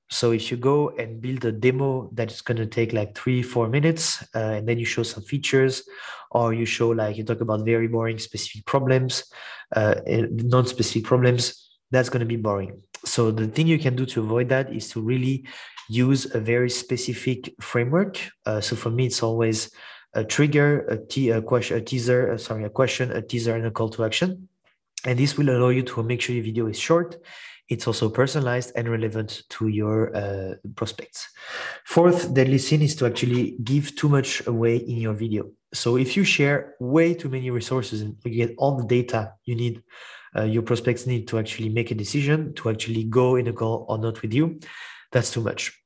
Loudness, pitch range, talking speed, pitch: -24 LUFS, 115-130 Hz, 205 wpm, 120 Hz